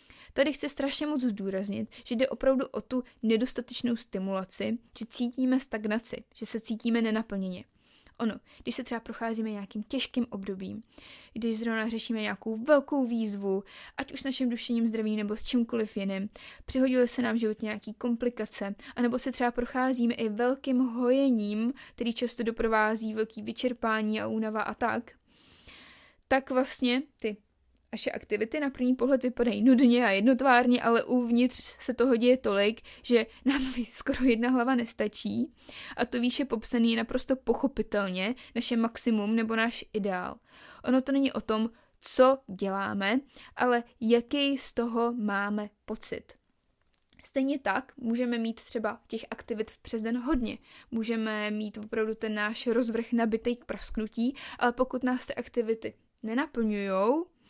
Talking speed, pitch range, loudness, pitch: 145 wpm, 220-255 Hz, -29 LUFS, 235 Hz